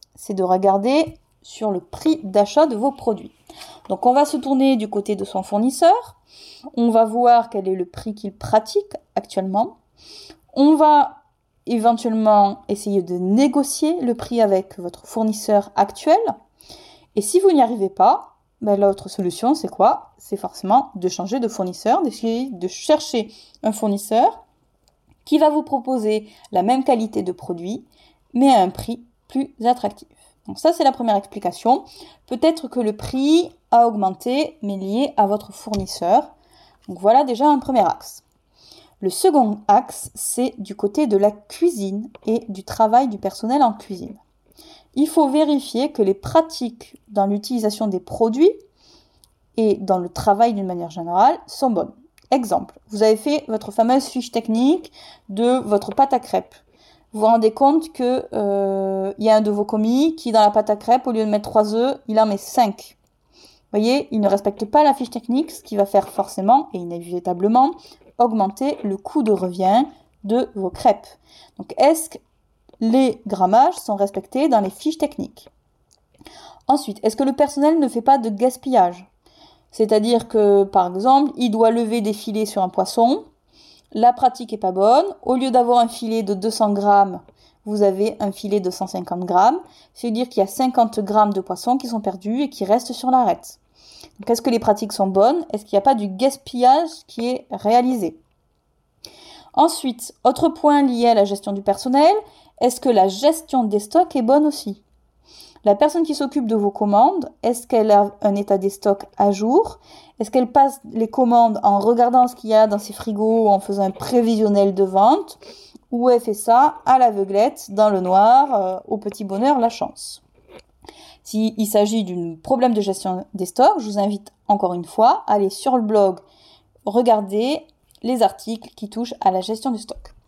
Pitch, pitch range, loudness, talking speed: 225 Hz, 205-270 Hz, -19 LUFS, 180 wpm